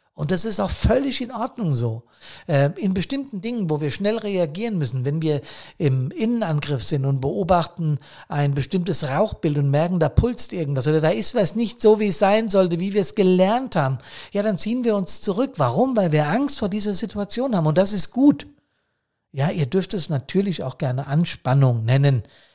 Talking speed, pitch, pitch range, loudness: 195 wpm, 185 Hz, 150-210 Hz, -21 LUFS